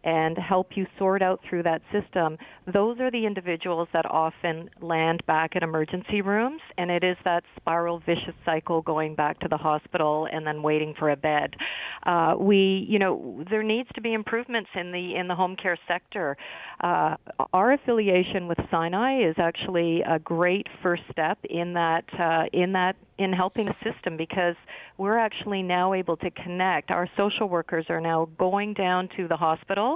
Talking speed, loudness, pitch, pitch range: 180 wpm, -26 LUFS, 180 Hz, 165-195 Hz